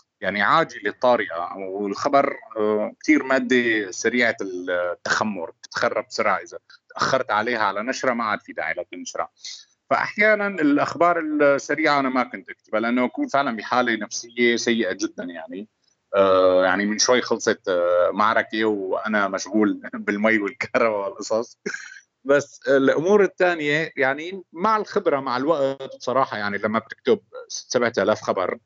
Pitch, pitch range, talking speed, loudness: 125 Hz, 105-145 Hz, 125 wpm, -22 LUFS